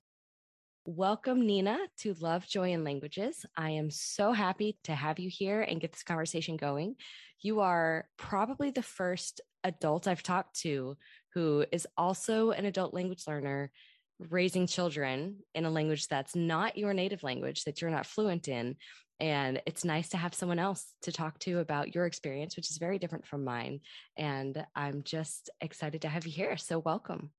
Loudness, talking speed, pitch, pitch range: -34 LUFS, 175 wpm, 170 Hz, 155-190 Hz